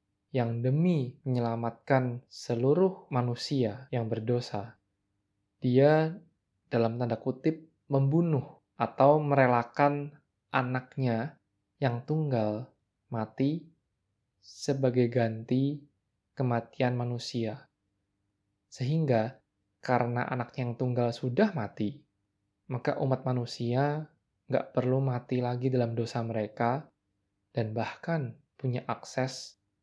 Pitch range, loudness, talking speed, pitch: 115-135 Hz, -30 LUFS, 85 wpm, 125 Hz